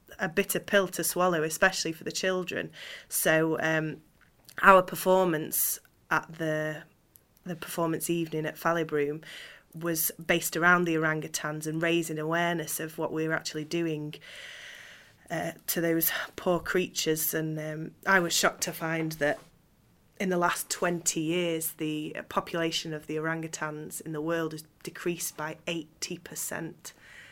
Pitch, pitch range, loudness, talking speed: 165 Hz, 155-175 Hz, -29 LUFS, 145 wpm